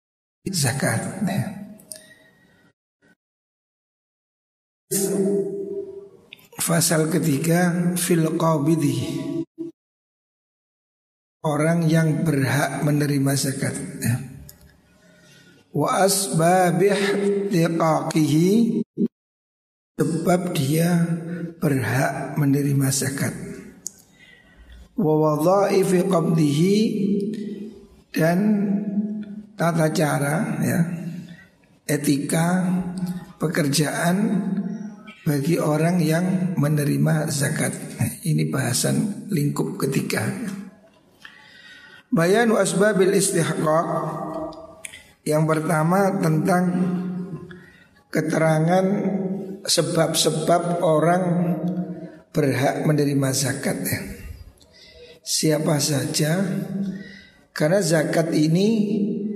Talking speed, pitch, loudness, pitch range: 55 wpm, 170 Hz, -21 LUFS, 155-195 Hz